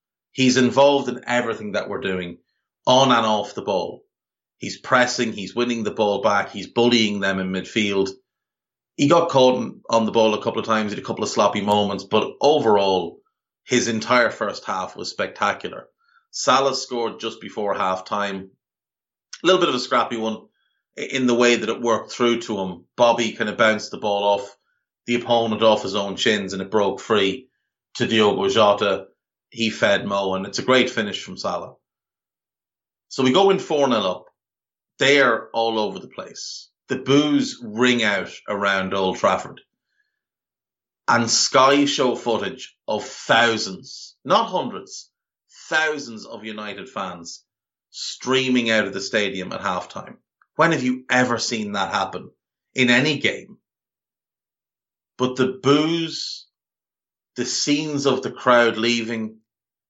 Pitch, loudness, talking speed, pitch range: 115 Hz, -20 LUFS, 160 wpm, 105-130 Hz